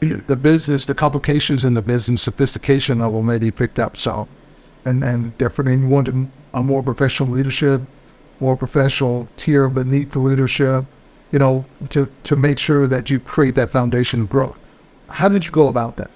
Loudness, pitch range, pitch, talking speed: -18 LUFS, 125-140 Hz, 135 Hz, 175 wpm